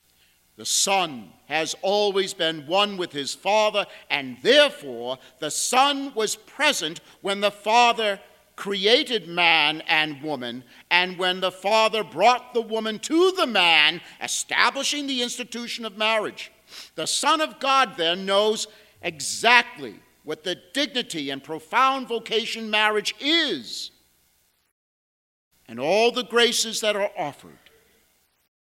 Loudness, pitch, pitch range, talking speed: -22 LUFS, 200 Hz, 155-235 Hz, 125 wpm